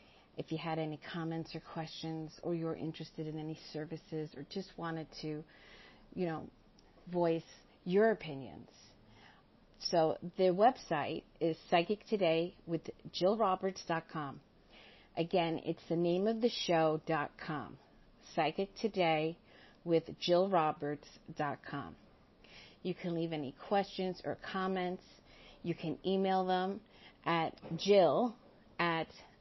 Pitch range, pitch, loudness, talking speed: 160-185 Hz, 165 Hz, -36 LUFS, 110 wpm